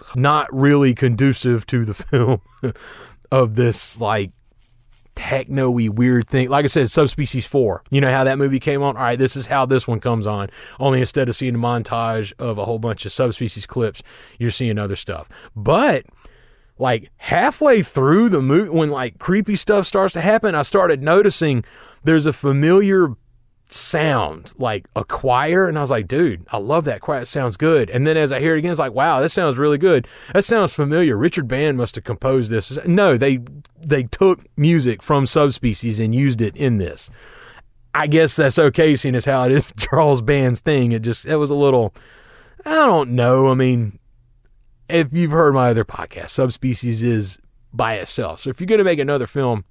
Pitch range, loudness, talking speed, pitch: 120-150 Hz, -18 LUFS, 195 wpm, 130 Hz